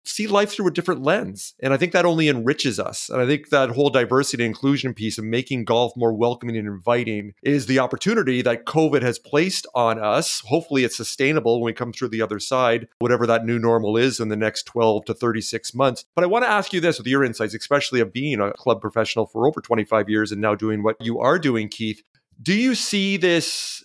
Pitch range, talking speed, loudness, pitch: 115-145 Hz, 230 wpm, -21 LUFS, 120 Hz